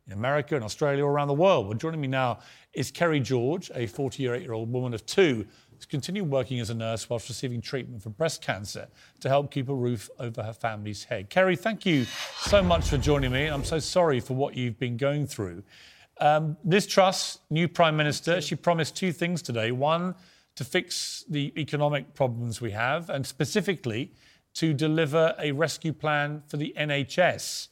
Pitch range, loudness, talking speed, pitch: 120-160 Hz, -27 LUFS, 190 wpm, 145 Hz